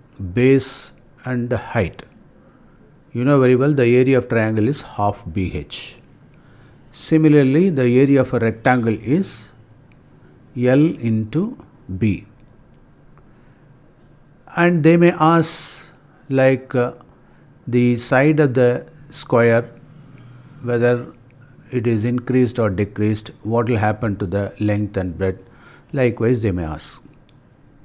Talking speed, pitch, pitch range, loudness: 115 wpm, 125 Hz, 115-140 Hz, -18 LUFS